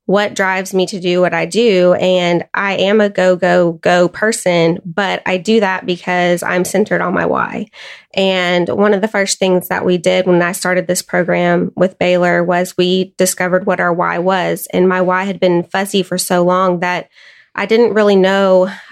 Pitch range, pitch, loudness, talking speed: 180-195 Hz, 185 Hz, -14 LUFS, 200 wpm